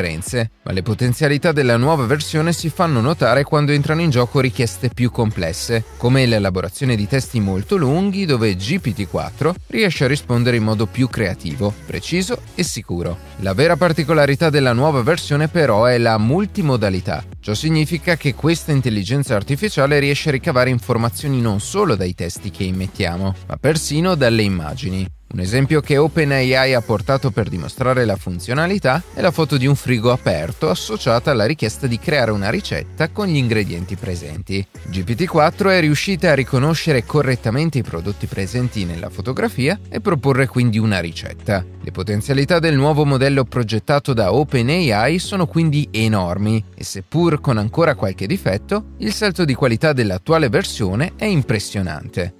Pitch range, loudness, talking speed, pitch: 105-150 Hz, -18 LUFS, 150 wpm, 125 Hz